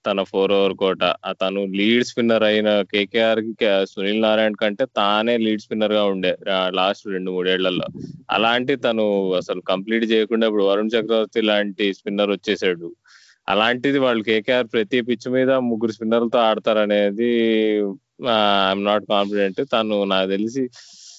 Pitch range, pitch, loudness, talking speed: 100-115 Hz, 105 Hz, -20 LUFS, 135 wpm